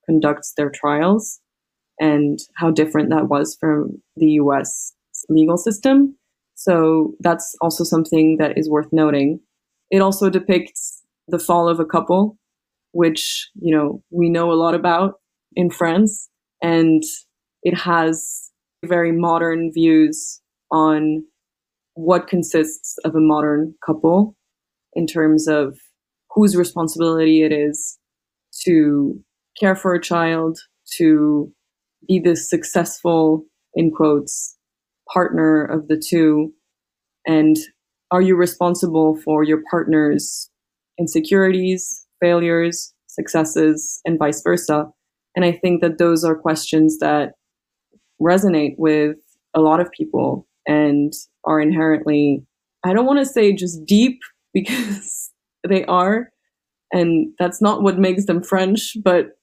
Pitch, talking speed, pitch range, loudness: 170 Hz, 125 wpm, 155-185 Hz, -17 LUFS